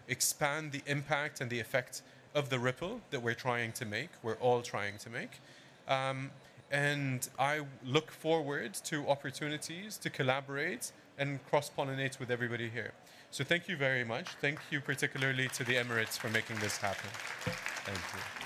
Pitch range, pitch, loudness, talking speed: 125-145 Hz, 135 Hz, -35 LUFS, 165 wpm